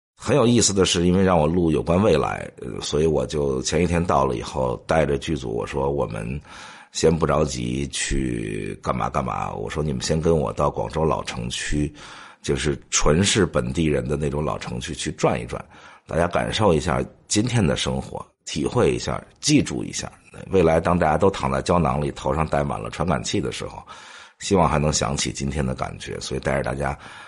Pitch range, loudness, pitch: 70-85 Hz, -22 LUFS, 75 Hz